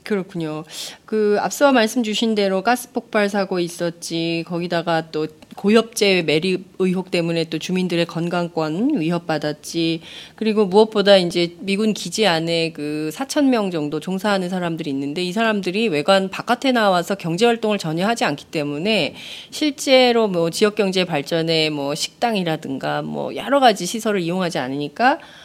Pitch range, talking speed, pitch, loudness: 165-215 Hz, 335 characters per minute, 185 Hz, -20 LUFS